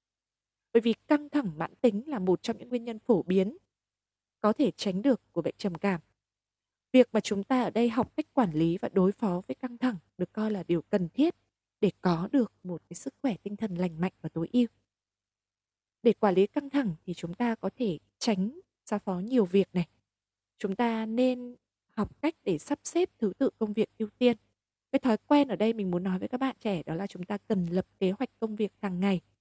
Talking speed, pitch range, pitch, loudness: 230 wpm, 180-240 Hz, 205 Hz, -30 LUFS